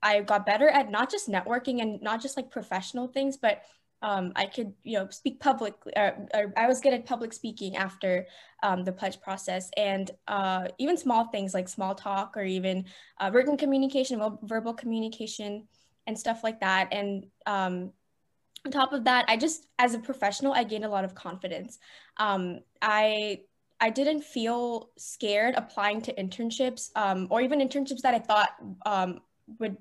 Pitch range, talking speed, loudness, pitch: 195-245 Hz, 175 wpm, -29 LUFS, 215 Hz